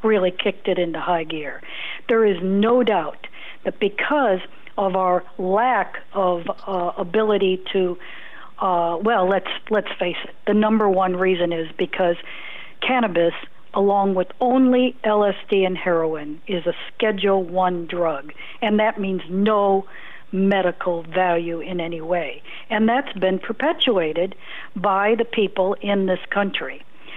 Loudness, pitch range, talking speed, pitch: -21 LUFS, 180-210 Hz, 135 wpm, 190 Hz